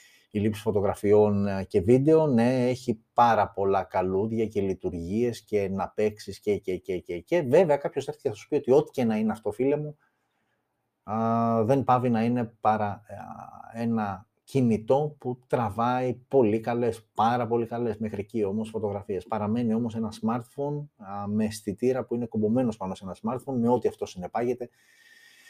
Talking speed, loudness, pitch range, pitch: 165 wpm, -27 LUFS, 105-125 Hz, 115 Hz